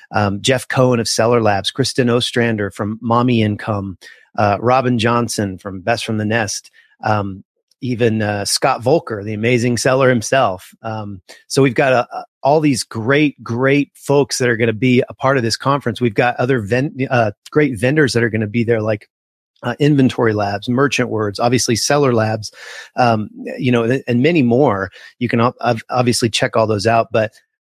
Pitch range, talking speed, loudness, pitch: 110-130 Hz, 185 wpm, -16 LUFS, 120 Hz